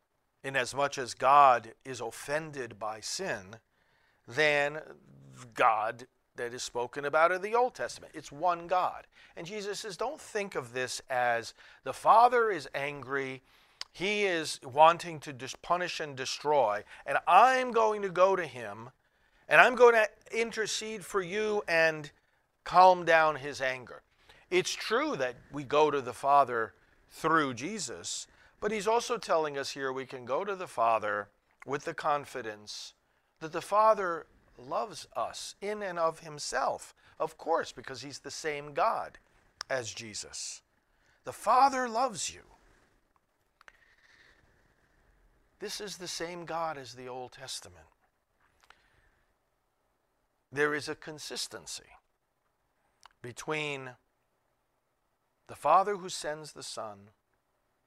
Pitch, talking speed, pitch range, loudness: 155 Hz, 130 wpm, 130-195 Hz, -30 LUFS